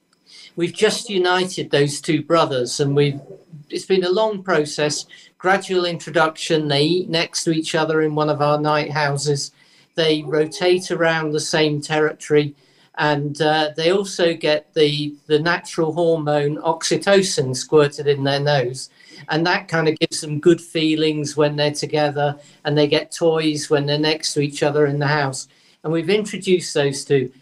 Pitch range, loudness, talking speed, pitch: 145-165 Hz, -19 LUFS, 165 wpm, 155 Hz